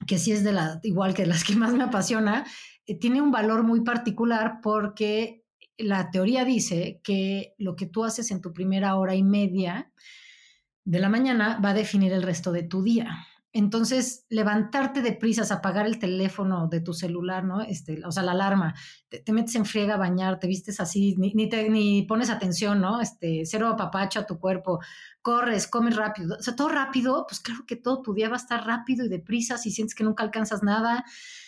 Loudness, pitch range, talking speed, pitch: -26 LUFS, 190-230 Hz, 210 wpm, 210 Hz